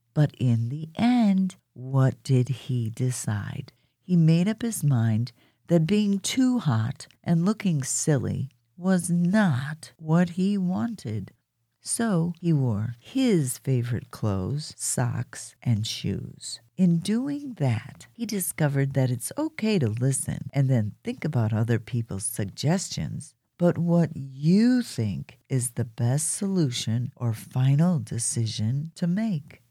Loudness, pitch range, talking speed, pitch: -26 LUFS, 120-175 Hz, 130 wpm, 140 Hz